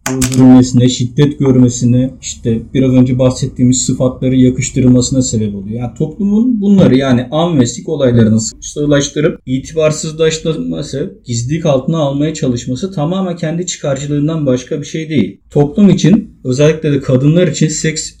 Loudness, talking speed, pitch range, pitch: -12 LUFS, 130 wpm, 125-160 Hz, 135 Hz